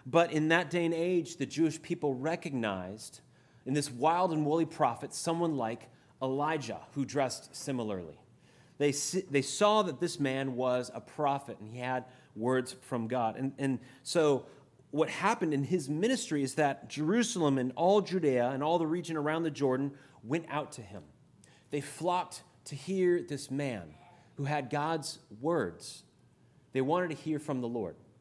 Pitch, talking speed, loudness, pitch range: 145 Hz, 170 wpm, -32 LUFS, 130-165 Hz